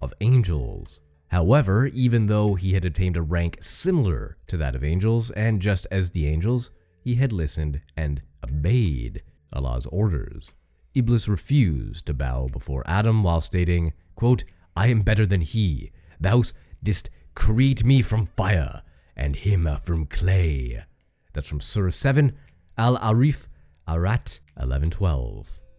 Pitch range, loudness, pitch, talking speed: 75-110 Hz, -23 LUFS, 90 Hz, 135 wpm